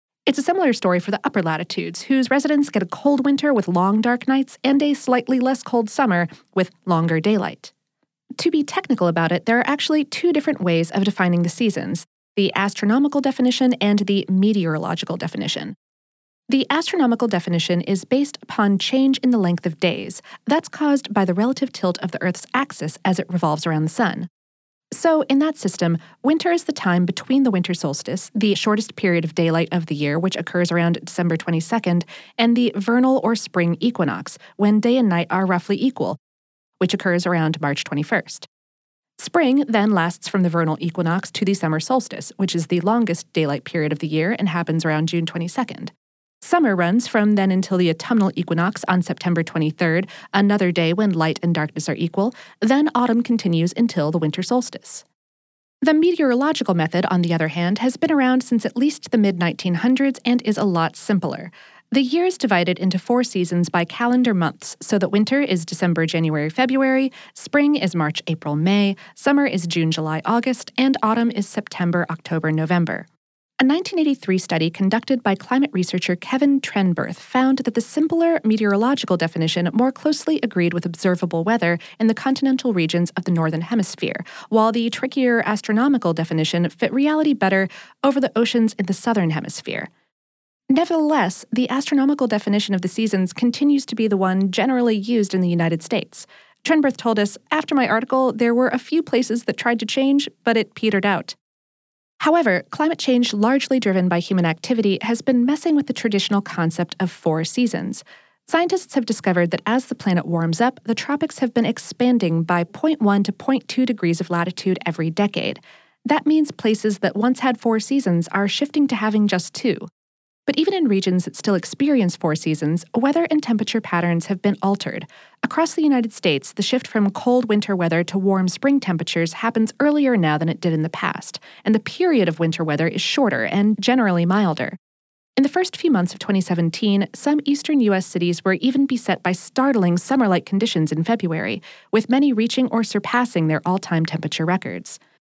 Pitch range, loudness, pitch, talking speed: 175-255 Hz, -20 LUFS, 205 Hz, 185 wpm